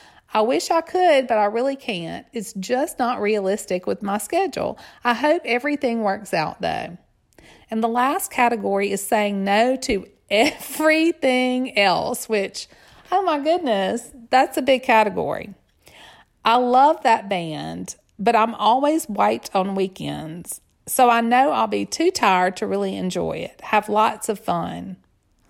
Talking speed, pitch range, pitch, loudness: 150 wpm, 200-265 Hz, 230 Hz, -21 LUFS